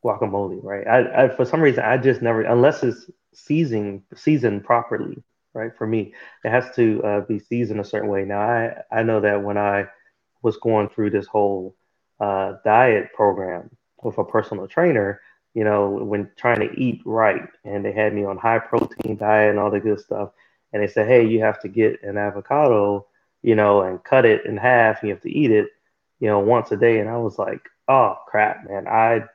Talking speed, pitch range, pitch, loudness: 210 wpm, 100-115 Hz, 105 Hz, -20 LUFS